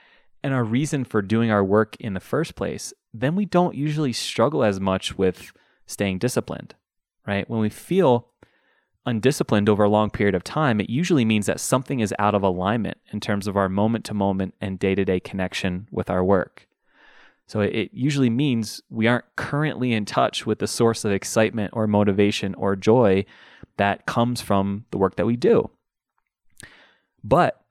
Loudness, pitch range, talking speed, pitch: -22 LUFS, 100-120 Hz, 180 wpm, 105 Hz